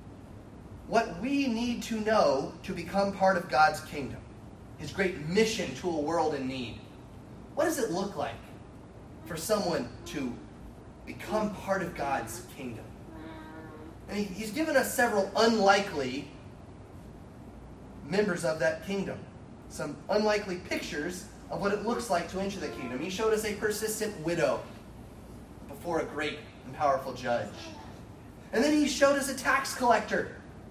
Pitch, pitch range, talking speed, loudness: 175 Hz, 130-215 Hz, 145 wpm, -30 LUFS